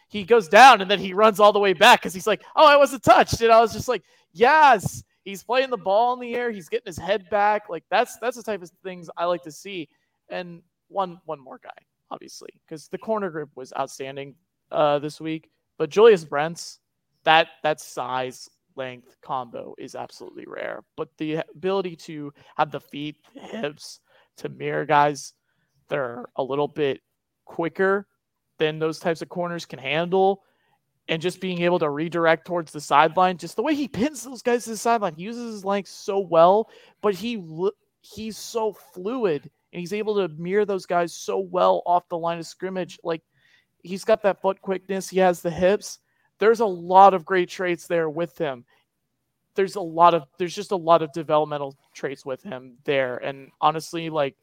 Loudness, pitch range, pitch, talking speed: -22 LUFS, 155-205 Hz, 175 Hz, 195 wpm